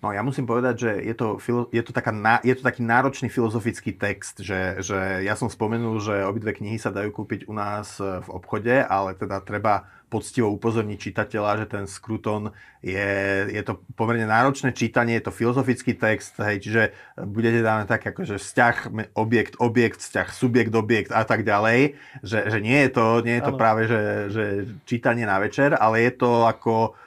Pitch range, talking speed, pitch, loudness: 105-120 Hz, 185 wpm, 110 Hz, -23 LUFS